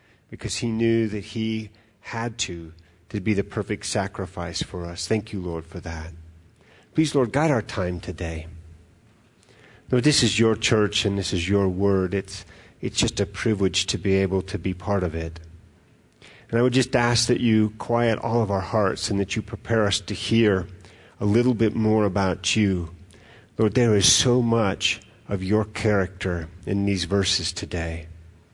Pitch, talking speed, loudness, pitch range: 100 Hz, 180 wpm, -23 LUFS, 90-110 Hz